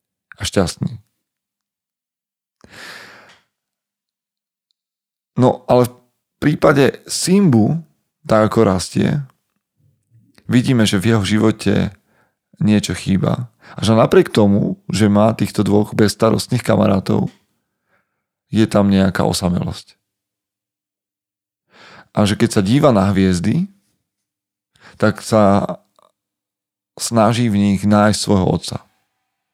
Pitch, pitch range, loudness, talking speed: 110 Hz, 100-125 Hz, -16 LUFS, 95 wpm